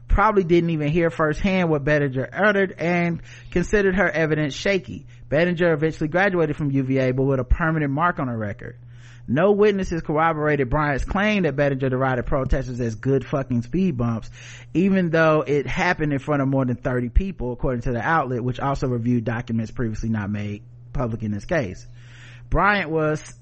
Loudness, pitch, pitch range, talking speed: -22 LUFS, 140 Hz, 120-165 Hz, 175 wpm